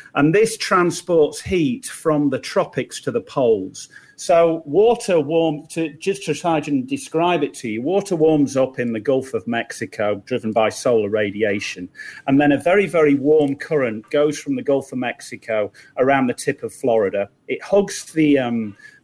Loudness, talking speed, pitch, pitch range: -19 LUFS, 170 wpm, 150 Hz, 125-175 Hz